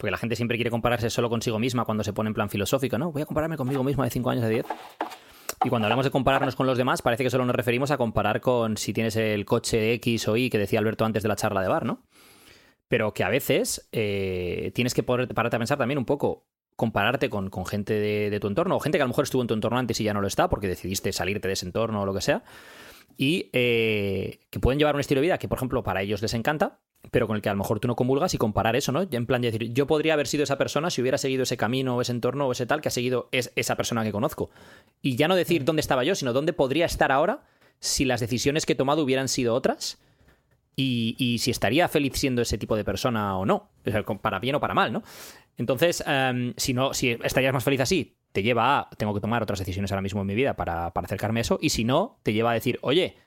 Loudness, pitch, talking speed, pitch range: -25 LUFS, 120 Hz, 275 wpm, 110-135 Hz